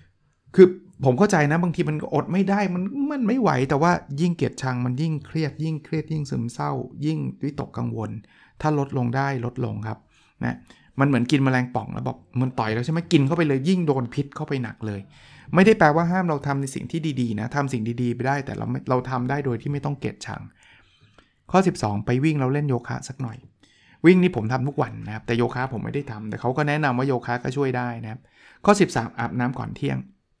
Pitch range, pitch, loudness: 120-155 Hz, 135 Hz, -23 LUFS